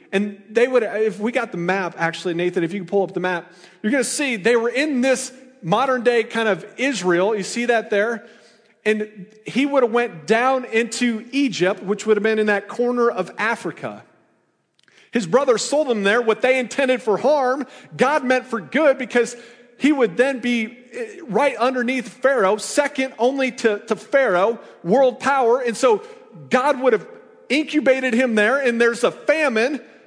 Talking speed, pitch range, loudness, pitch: 180 wpm, 215-265 Hz, -20 LUFS, 240 Hz